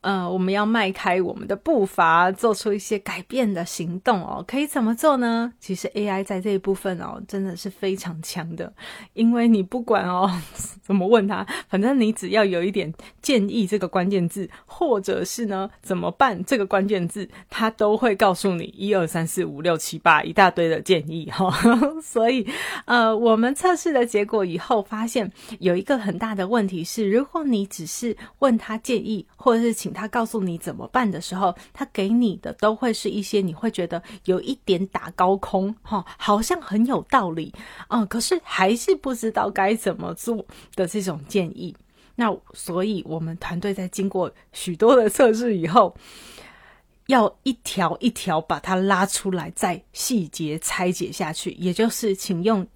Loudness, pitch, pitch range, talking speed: -22 LUFS, 200 Hz, 185-230 Hz, 265 characters per minute